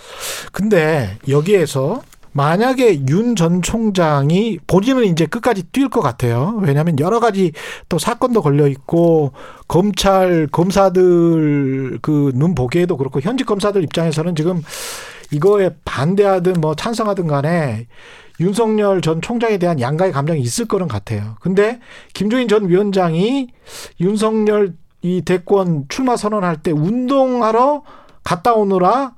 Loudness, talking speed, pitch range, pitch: -16 LUFS, 280 characters per minute, 155-215 Hz, 180 Hz